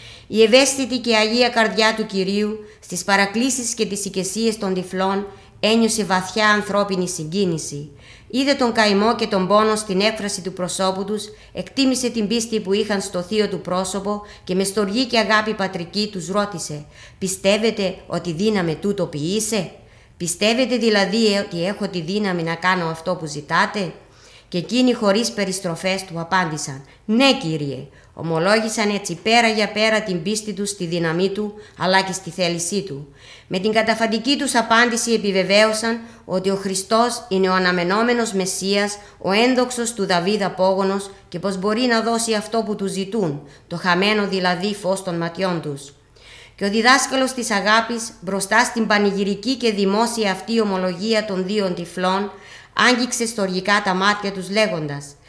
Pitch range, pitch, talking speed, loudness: 185-220 Hz, 200 Hz, 155 wpm, -19 LUFS